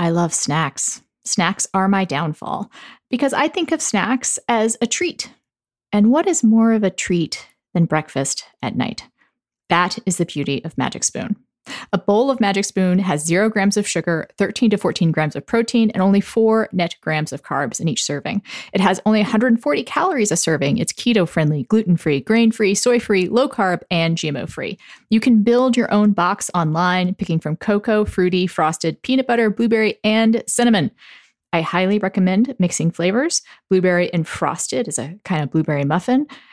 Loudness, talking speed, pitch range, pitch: -18 LUFS, 180 wpm, 170-230 Hz, 200 Hz